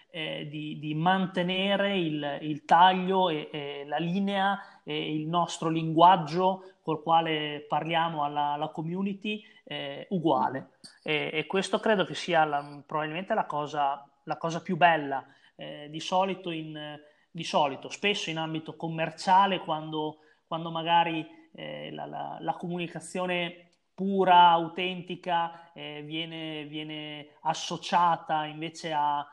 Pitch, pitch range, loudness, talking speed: 165 Hz, 150-180 Hz, -28 LUFS, 130 wpm